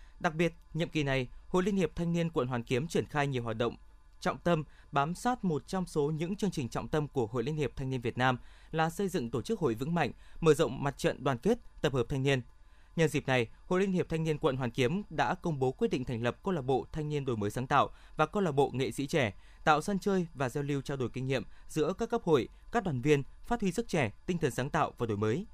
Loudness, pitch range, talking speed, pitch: -32 LUFS, 130-170 Hz, 275 wpm, 150 Hz